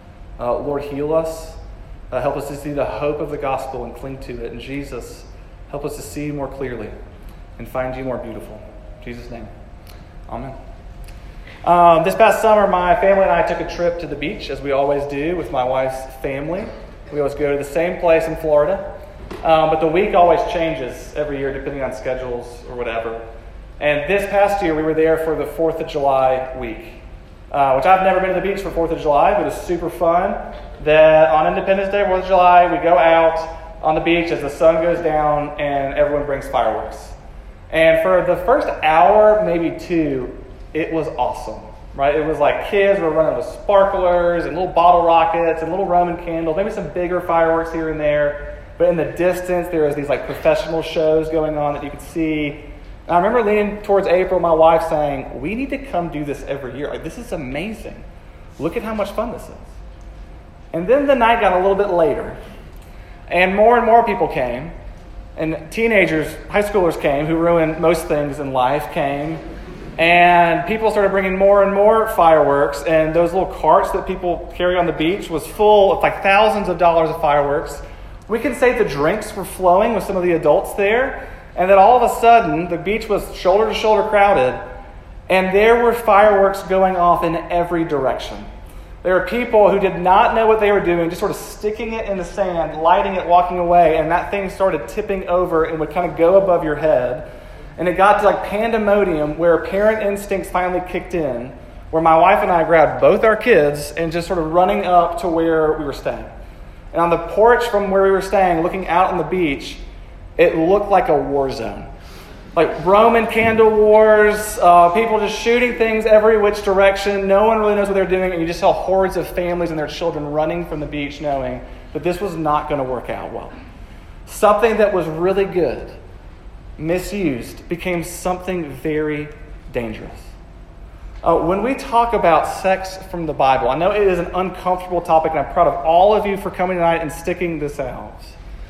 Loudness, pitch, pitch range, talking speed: -16 LUFS, 165 Hz, 145-190 Hz, 200 wpm